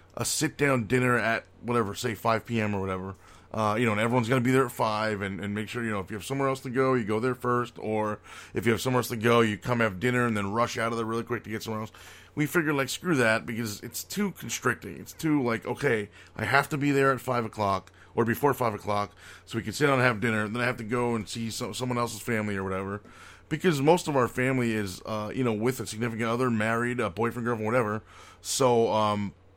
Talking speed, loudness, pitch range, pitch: 265 wpm, -27 LUFS, 105-125 Hz, 115 Hz